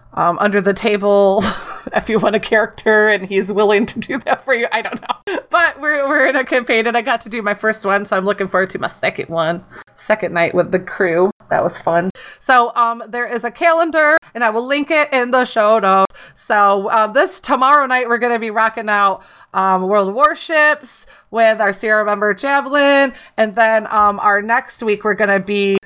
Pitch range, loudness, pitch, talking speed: 205-255 Hz, -15 LUFS, 220 Hz, 215 wpm